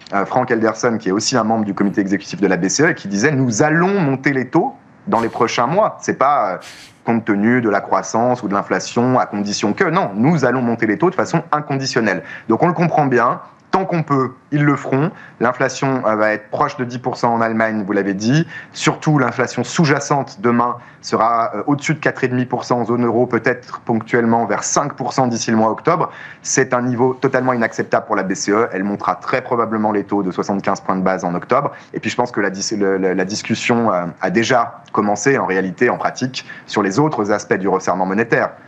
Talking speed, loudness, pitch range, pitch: 205 wpm, -17 LUFS, 105-135 Hz, 120 Hz